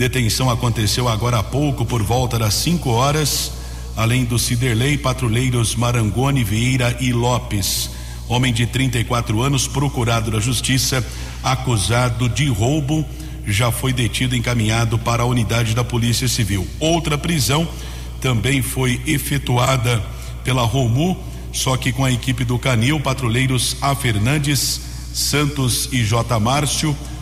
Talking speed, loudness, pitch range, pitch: 130 wpm, -18 LUFS, 115-130 Hz, 125 Hz